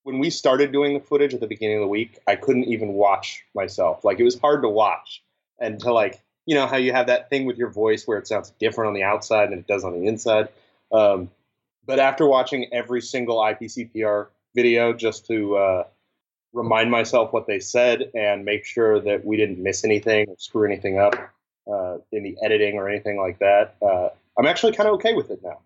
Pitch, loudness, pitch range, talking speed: 110 Hz, -21 LUFS, 105-125 Hz, 220 wpm